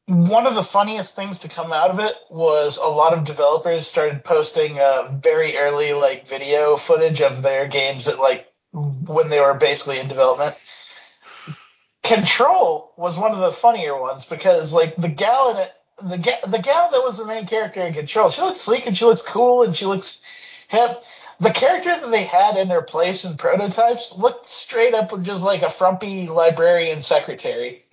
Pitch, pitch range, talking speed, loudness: 180 Hz, 150-230 Hz, 190 wpm, -18 LUFS